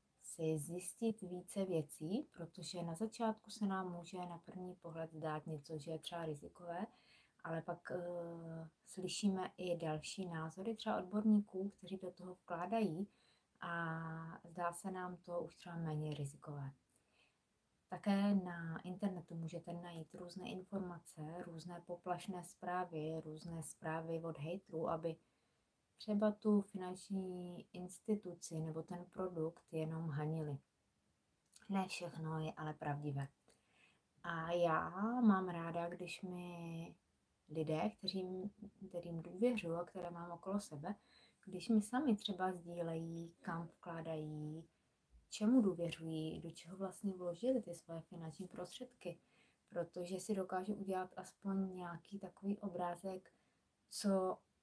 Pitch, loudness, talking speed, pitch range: 175 Hz, -44 LUFS, 120 wpm, 165-190 Hz